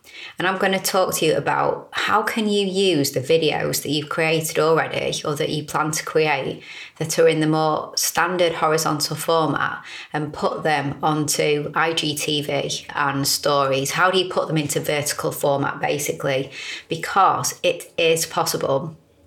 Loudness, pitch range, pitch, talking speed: -21 LUFS, 150-185 Hz, 160 Hz, 160 wpm